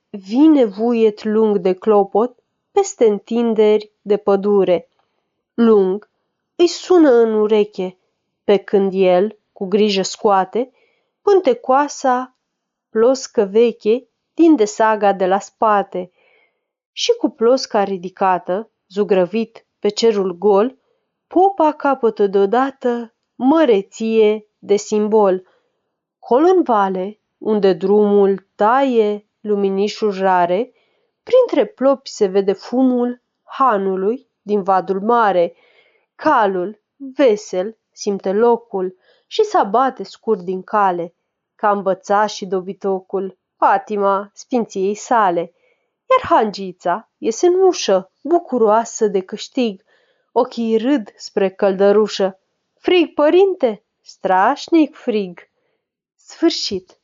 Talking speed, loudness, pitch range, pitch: 100 wpm, -17 LUFS, 200-260 Hz, 215 Hz